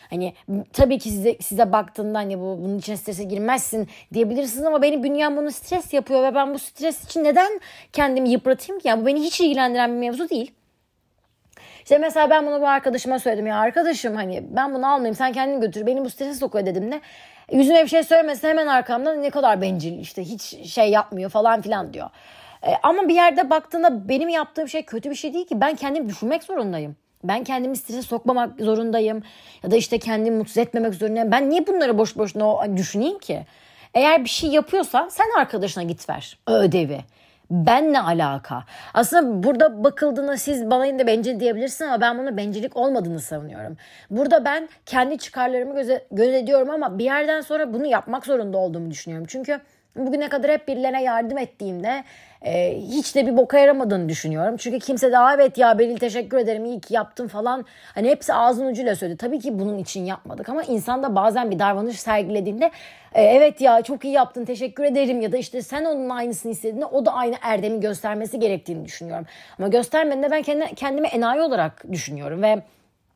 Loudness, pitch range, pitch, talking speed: -21 LUFS, 215-285 Hz, 250 Hz, 185 wpm